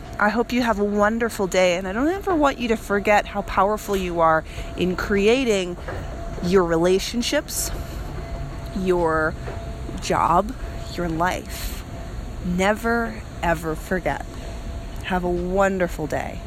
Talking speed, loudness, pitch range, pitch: 125 wpm, -22 LUFS, 165-215 Hz, 190 Hz